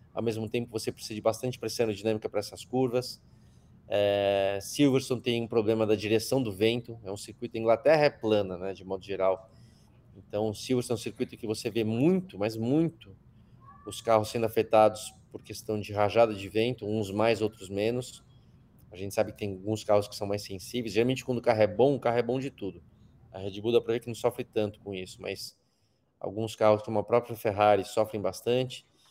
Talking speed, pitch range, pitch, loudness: 210 wpm, 105-120 Hz, 110 Hz, -29 LUFS